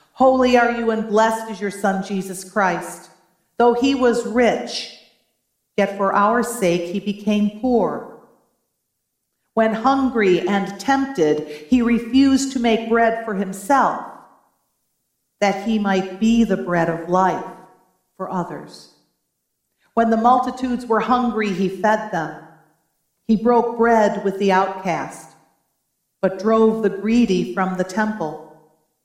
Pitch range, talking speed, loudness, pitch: 185-230 Hz, 130 wpm, -19 LUFS, 200 Hz